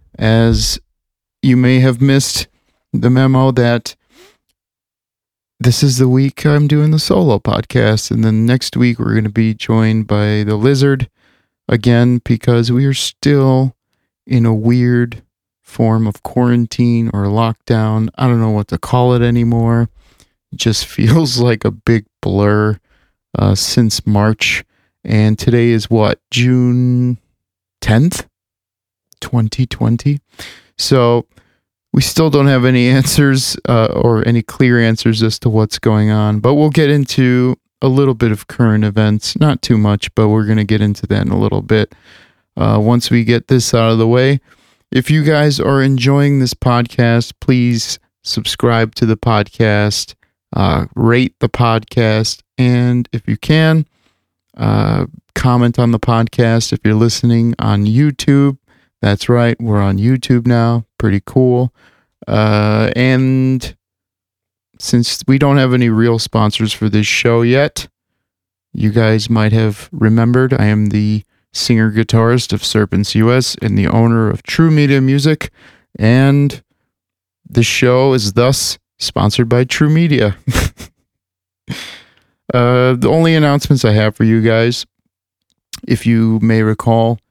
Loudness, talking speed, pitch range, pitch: -13 LUFS, 145 wpm, 110-125 Hz, 115 Hz